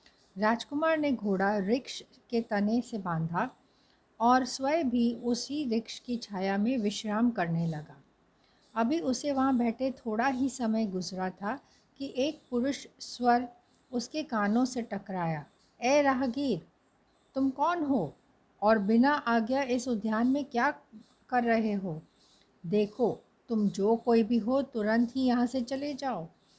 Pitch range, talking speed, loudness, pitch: 215-265 Hz, 140 wpm, -30 LUFS, 235 Hz